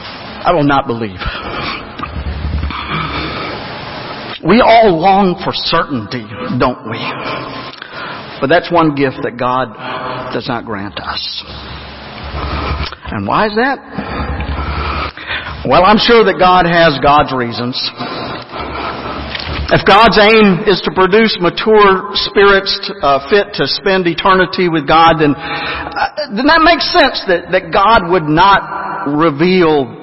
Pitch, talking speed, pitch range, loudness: 165 Hz, 120 wpm, 120-200 Hz, -12 LUFS